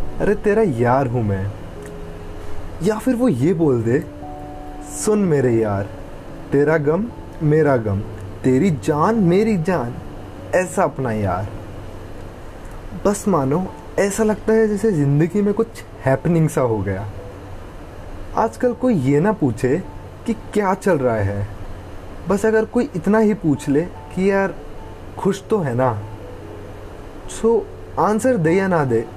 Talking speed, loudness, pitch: 140 wpm, -19 LUFS, 135 Hz